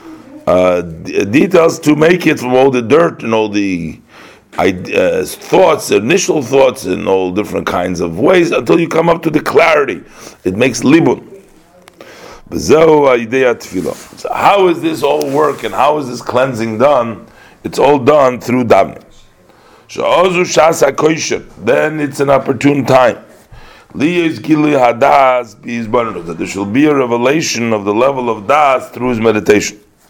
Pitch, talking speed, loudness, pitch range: 135 Hz, 135 wpm, -12 LUFS, 115-155 Hz